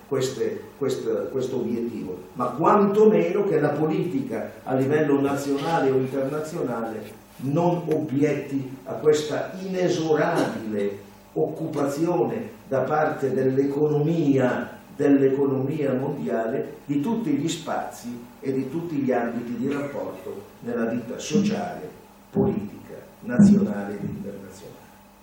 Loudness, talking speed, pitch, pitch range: -24 LUFS, 100 wpm, 145 Hz, 130-165 Hz